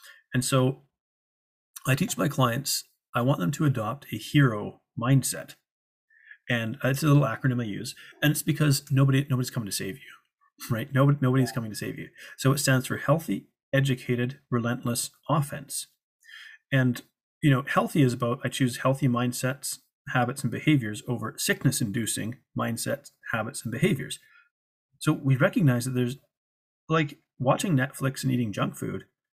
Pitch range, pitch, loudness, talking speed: 125-145 Hz, 130 Hz, -27 LUFS, 155 wpm